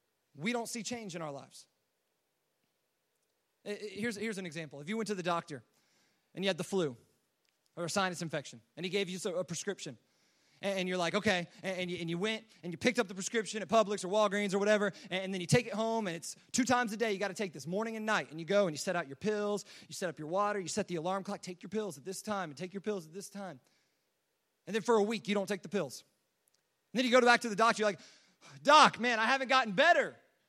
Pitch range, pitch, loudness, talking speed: 180-220 Hz, 200 Hz, -33 LUFS, 255 wpm